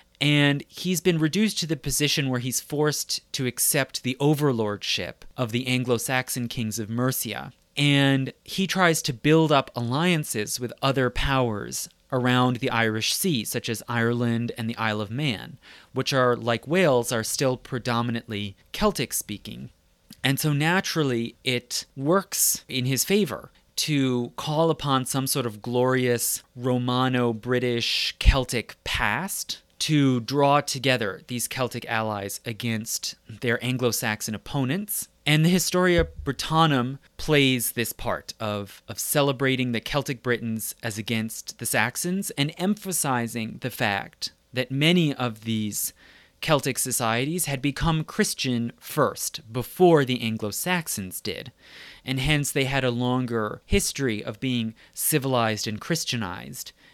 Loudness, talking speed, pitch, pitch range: -25 LUFS, 135 wpm, 125 Hz, 115-145 Hz